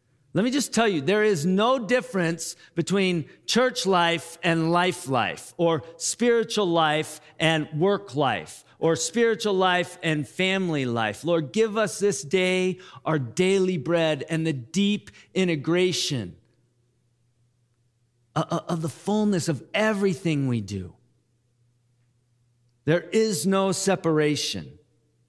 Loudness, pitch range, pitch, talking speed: -24 LUFS, 130-190 Hz, 165 Hz, 120 wpm